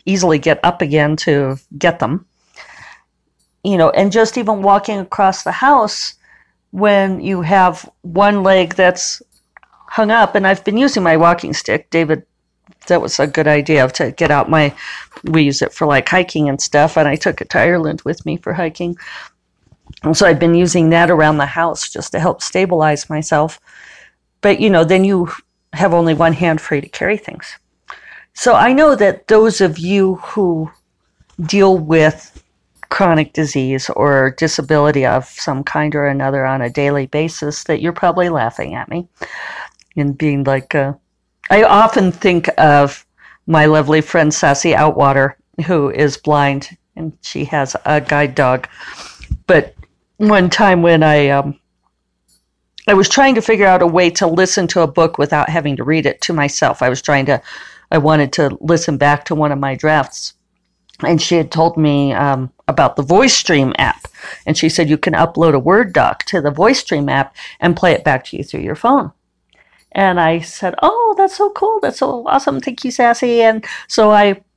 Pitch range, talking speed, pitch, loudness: 150-190 Hz, 180 wpm, 165 Hz, -13 LUFS